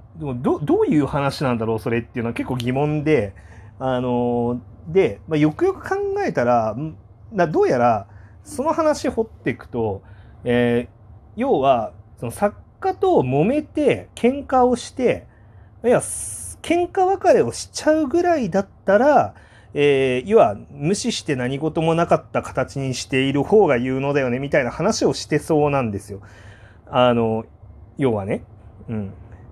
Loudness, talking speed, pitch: -20 LUFS, 285 characters per minute, 130 Hz